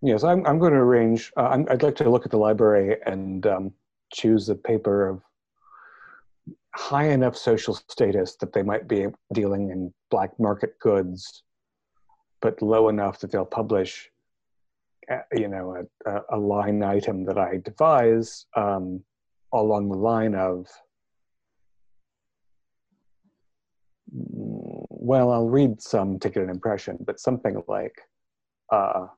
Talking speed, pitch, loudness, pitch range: 135 wpm, 105 Hz, -23 LUFS, 95-115 Hz